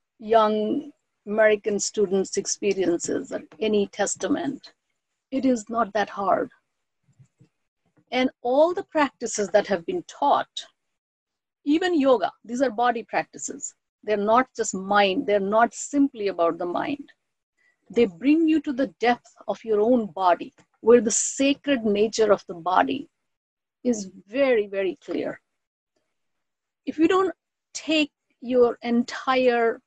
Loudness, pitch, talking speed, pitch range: -23 LUFS, 235 Hz, 125 wpm, 205-280 Hz